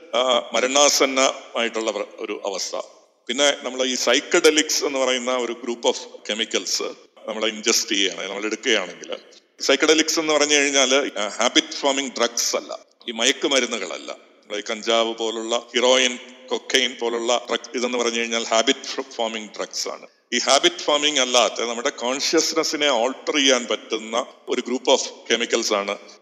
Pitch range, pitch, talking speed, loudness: 120-150 Hz, 130 Hz, 130 wpm, -20 LUFS